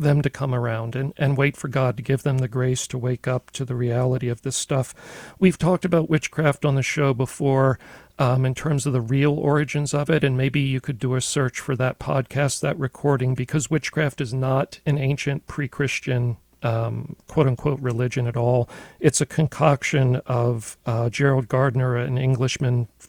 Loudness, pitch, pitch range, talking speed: -23 LUFS, 135 Hz, 125-145 Hz, 195 wpm